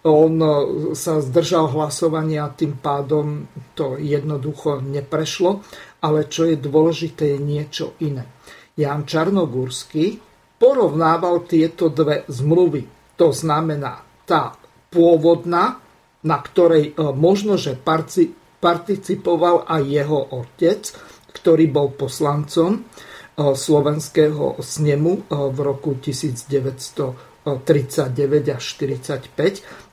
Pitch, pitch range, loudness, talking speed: 155 Hz, 145-165 Hz, -19 LUFS, 90 wpm